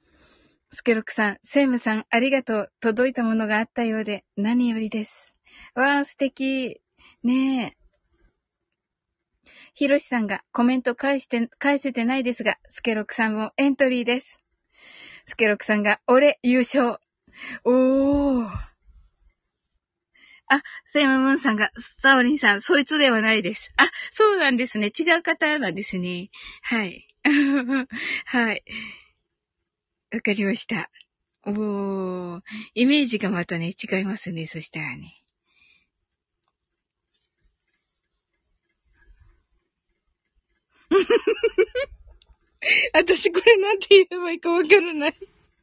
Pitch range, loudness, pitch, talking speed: 215-285 Hz, -21 LUFS, 245 Hz, 230 characters per minute